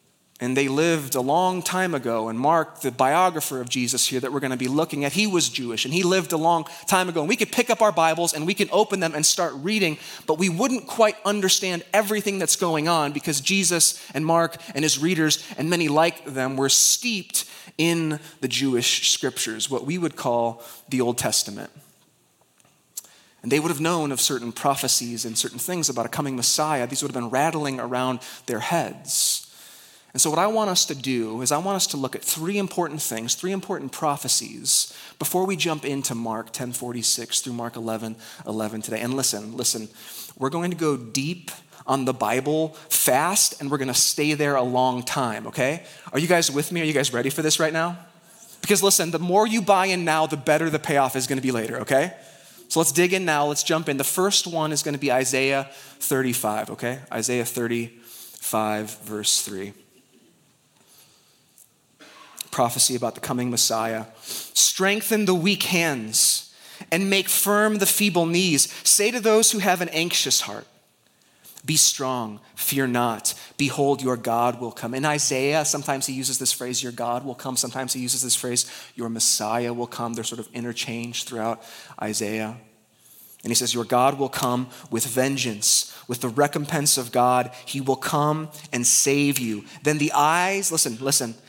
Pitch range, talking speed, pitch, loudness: 125-165 Hz, 190 wpm, 140 Hz, -22 LUFS